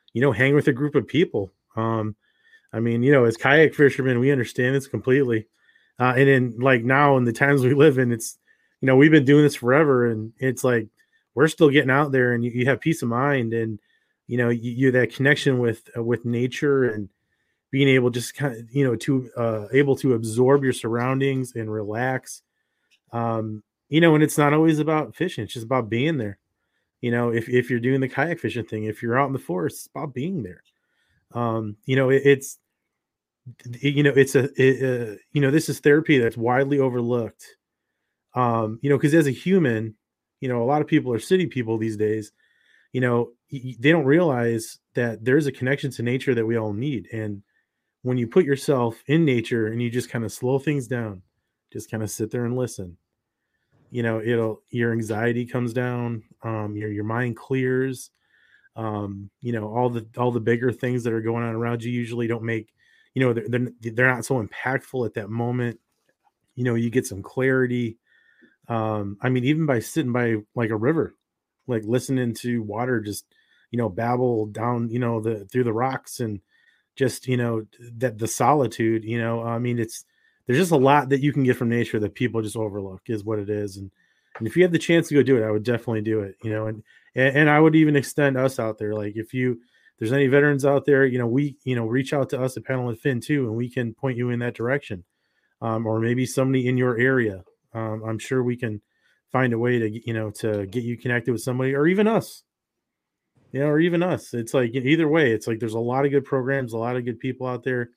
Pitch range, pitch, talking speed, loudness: 115-135 Hz, 125 Hz, 225 wpm, -22 LUFS